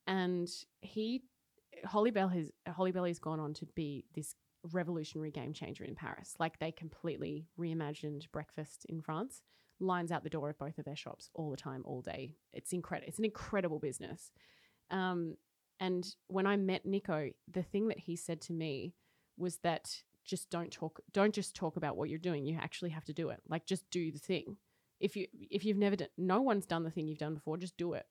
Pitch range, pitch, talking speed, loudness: 155-185 Hz, 170 Hz, 210 wpm, -39 LUFS